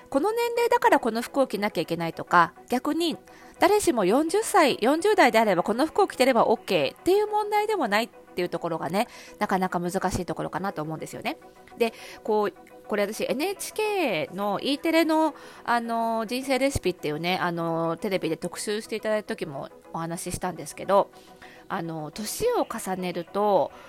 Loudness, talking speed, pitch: -25 LUFS, 350 characters per minute, 215 Hz